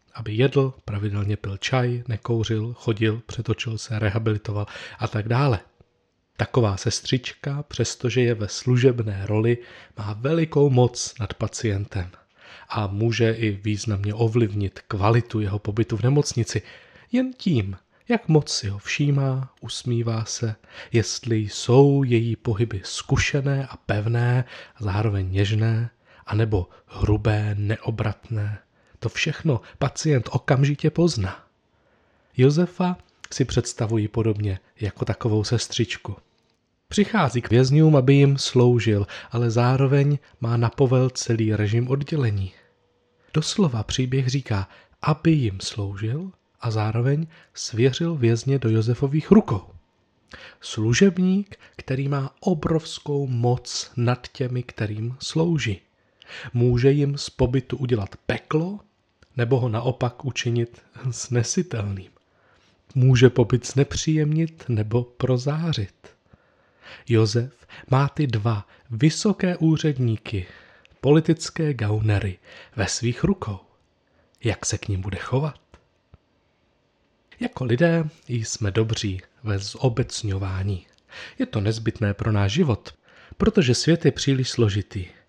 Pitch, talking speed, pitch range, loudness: 120 Hz, 110 wpm, 105-135 Hz, -23 LUFS